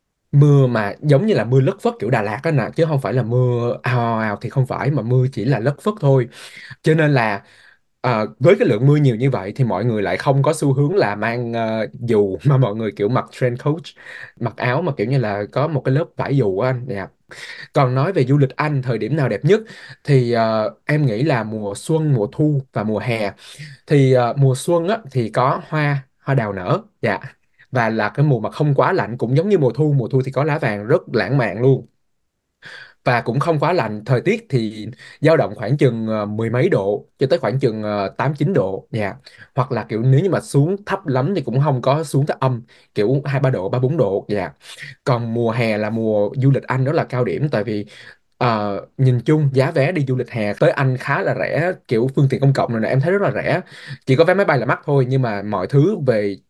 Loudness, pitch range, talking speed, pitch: -18 LUFS, 115-145 Hz, 250 wpm, 130 Hz